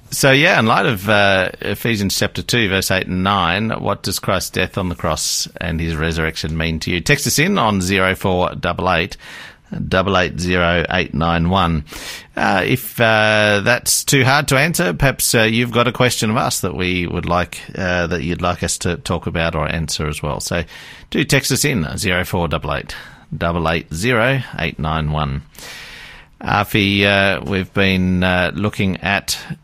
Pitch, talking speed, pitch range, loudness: 95 Hz, 185 wpm, 85-110 Hz, -17 LUFS